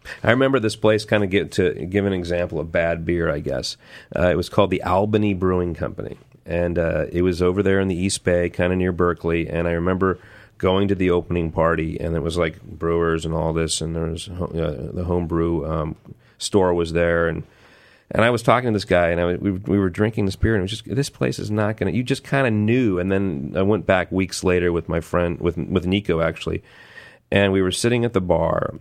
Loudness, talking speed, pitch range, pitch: -21 LUFS, 240 wpm, 85-100 Hz, 90 Hz